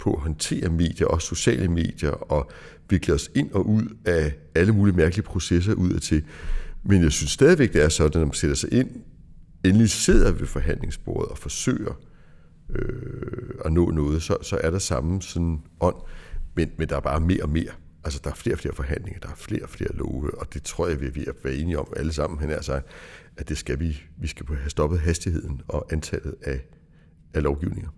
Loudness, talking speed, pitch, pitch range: -24 LUFS, 215 wpm, 80 Hz, 75-95 Hz